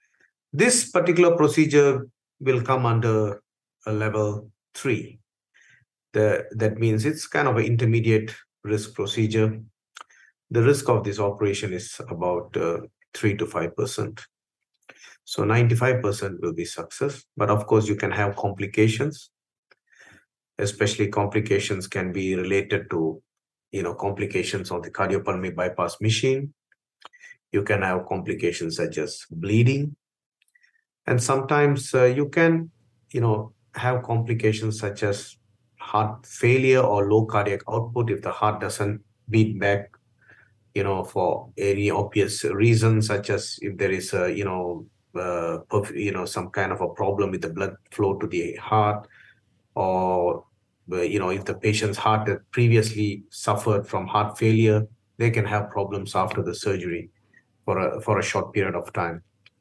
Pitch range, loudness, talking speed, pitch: 100-120 Hz, -24 LUFS, 145 wpm, 110 Hz